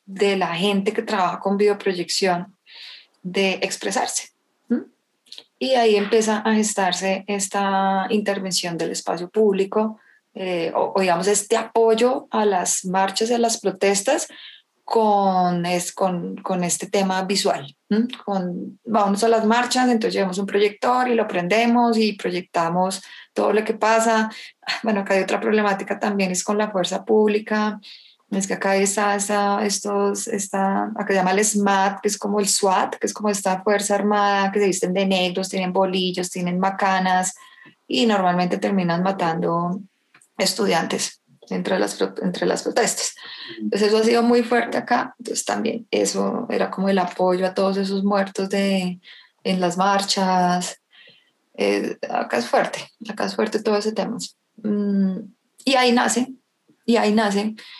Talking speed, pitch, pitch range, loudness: 155 wpm, 200 Hz, 190-220 Hz, -21 LUFS